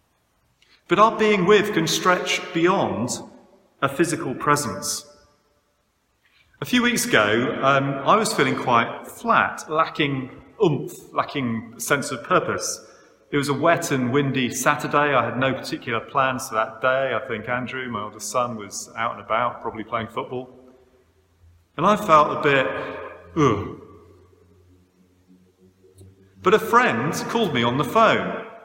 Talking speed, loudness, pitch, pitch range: 140 wpm, -21 LUFS, 135 Hz, 110-170 Hz